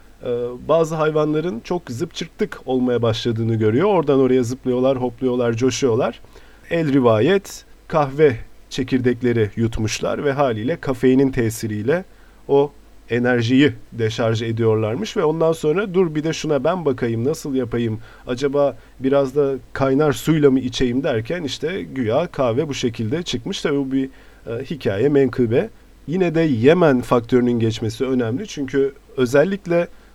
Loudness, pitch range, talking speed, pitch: -19 LUFS, 120-150 Hz, 125 wpm, 135 Hz